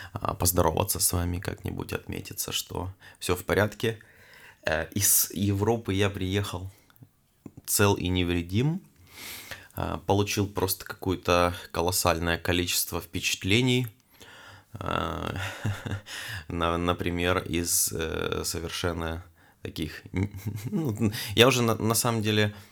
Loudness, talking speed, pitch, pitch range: -27 LUFS, 80 wpm, 100 Hz, 90-110 Hz